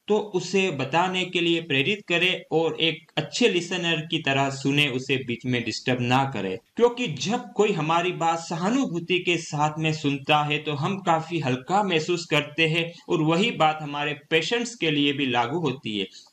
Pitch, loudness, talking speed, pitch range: 160 Hz, -24 LUFS, 180 wpm, 145-180 Hz